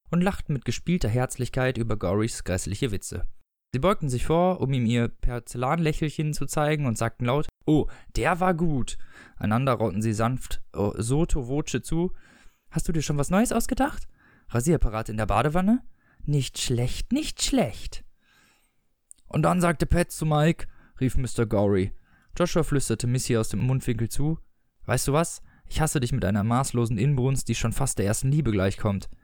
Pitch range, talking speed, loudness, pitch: 115-155 Hz, 170 wpm, -26 LUFS, 130 Hz